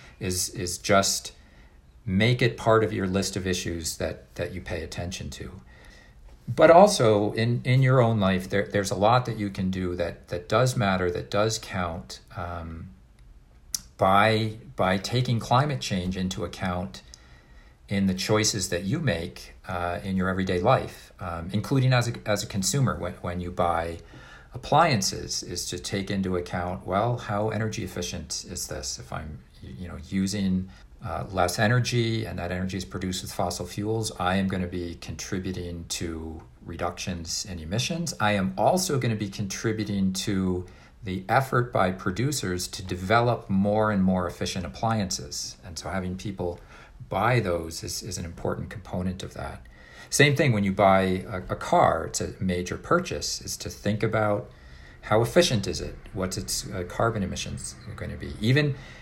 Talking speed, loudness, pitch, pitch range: 170 wpm, -26 LUFS, 95 Hz, 90-110 Hz